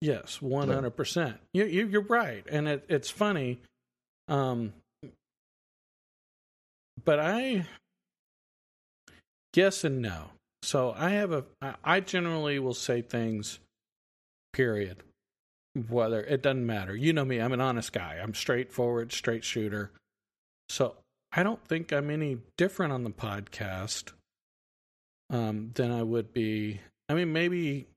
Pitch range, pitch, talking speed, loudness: 110-155 Hz, 125 Hz, 130 wpm, -30 LUFS